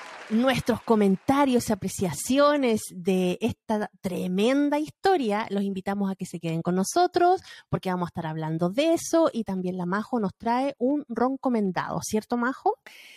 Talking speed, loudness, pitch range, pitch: 150 wpm, -26 LUFS, 185-265 Hz, 220 Hz